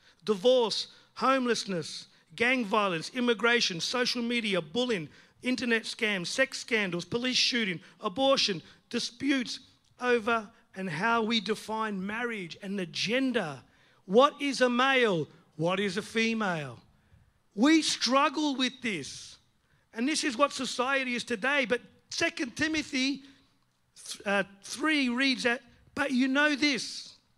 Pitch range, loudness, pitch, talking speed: 200-260 Hz, -28 LUFS, 235 Hz, 125 wpm